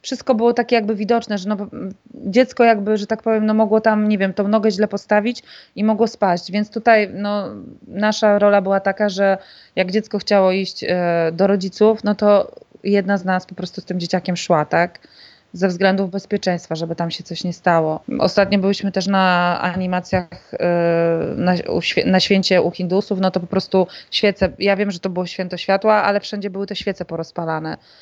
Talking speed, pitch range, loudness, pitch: 195 wpm, 180-210 Hz, -18 LUFS, 195 Hz